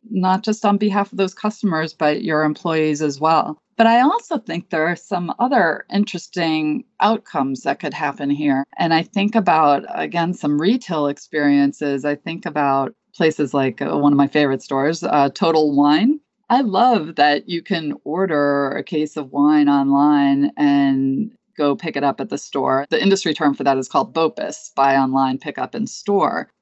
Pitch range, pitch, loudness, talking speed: 145-205 Hz, 160 Hz, -18 LUFS, 185 wpm